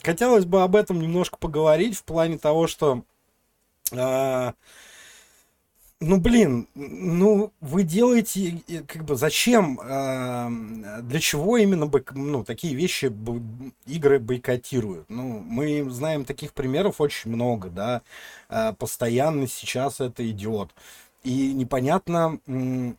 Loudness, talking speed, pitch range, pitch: -24 LUFS, 120 wpm, 125-170 Hz, 140 Hz